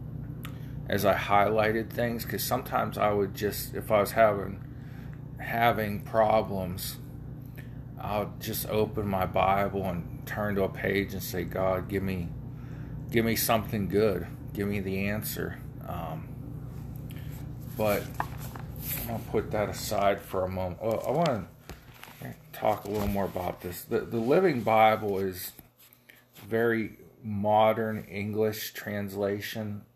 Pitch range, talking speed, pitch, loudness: 100-130 Hz, 135 wpm, 110 Hz, -29 LUFS